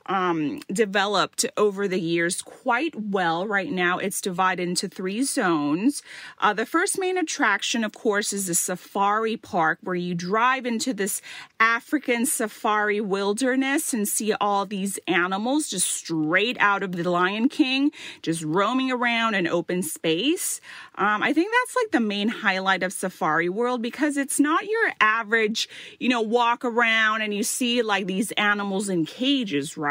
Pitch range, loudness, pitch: 190-255 Hz, -23 LUFS, 215 Hz